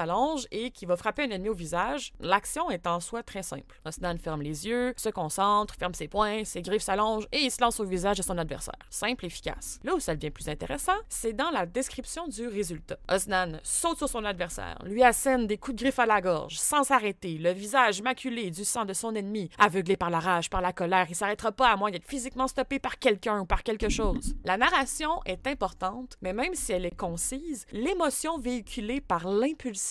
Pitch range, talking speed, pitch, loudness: 185-255 Hz, 220 wpm, 210 Hz, -29 LUFS